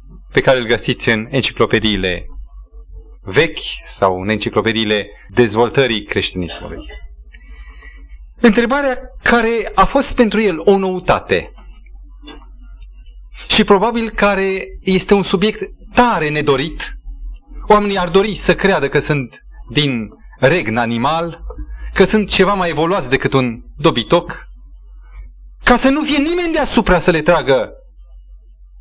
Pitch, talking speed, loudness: 145 Hz, 115 wpm, -15 LUFS